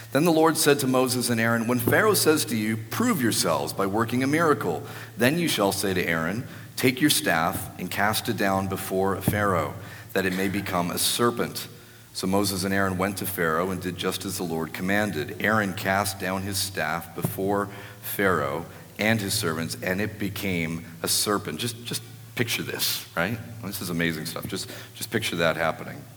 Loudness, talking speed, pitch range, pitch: -25 LUFS, 195 wpm, 95-120 Hz, 100 Hz